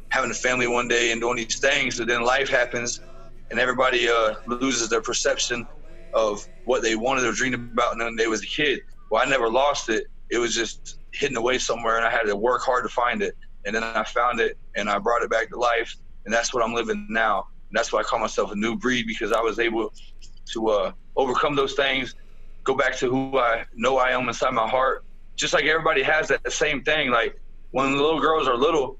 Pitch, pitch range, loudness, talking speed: 120 Hz, 115-130 Hz, -23 LUFS, 235 wpm